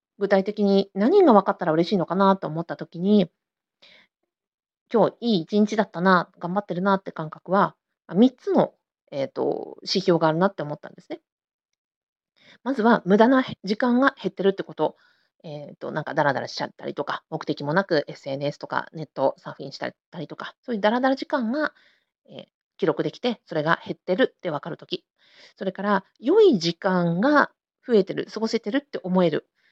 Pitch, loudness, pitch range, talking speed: 195 Hz, -23 LUFS, 170-230 Hz, 350 characters per minute